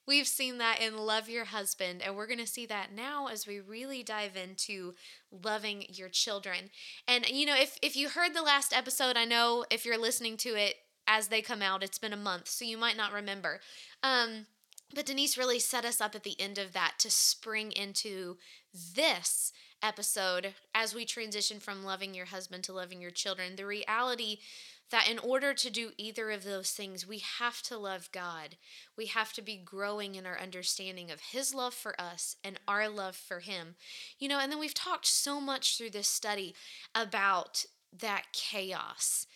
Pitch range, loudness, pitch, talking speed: 195-240 Hz, -33 LUFS, 215 Hz, 195 wpm